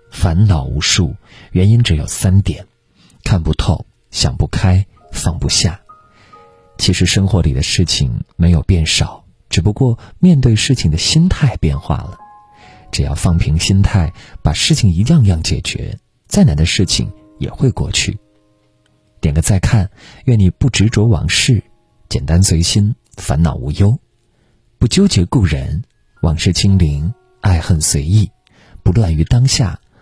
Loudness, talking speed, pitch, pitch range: -14 LUFS, 210 characters per minute, 100 Hz, 85-115 Hz